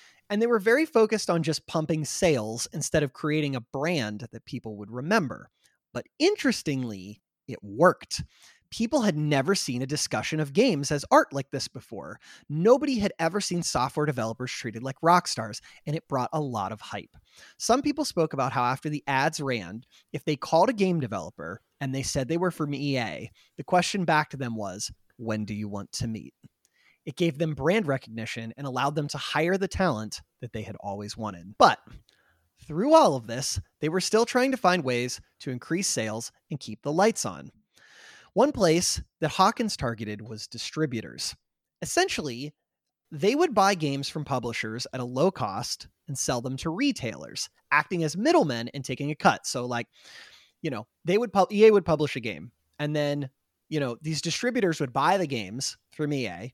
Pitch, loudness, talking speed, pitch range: 145 Hz, -27 LUFS, 185 wpm, 120-175 Hz